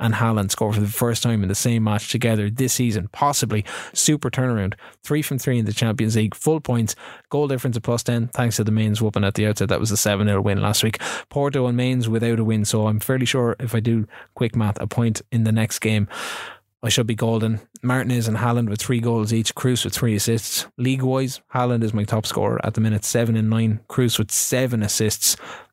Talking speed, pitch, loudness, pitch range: 235 wpm, 115 Hz, -21 LUFS, 110-125 Hz